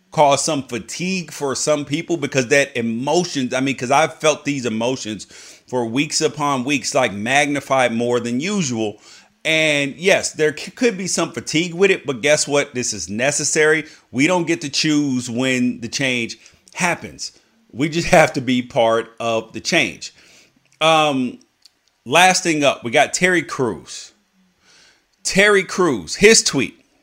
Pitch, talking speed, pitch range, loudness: 145 Hz, 160 wpm, 125-165 Hz, -18 LUFS